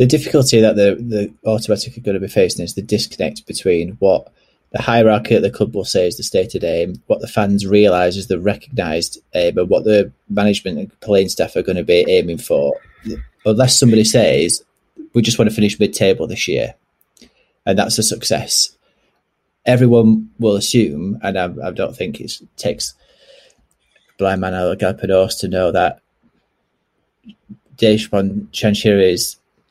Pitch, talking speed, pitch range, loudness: 110 Hz, 170 wpm, 100-120 Hz, -16 LUFS